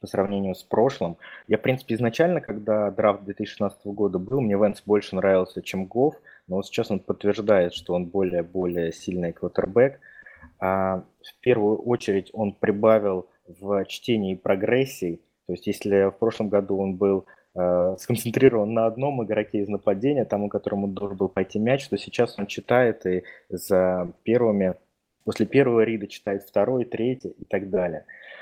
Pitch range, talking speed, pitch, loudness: 95-110 Hz, 155 wpm, 100 Hz, -24 LUFS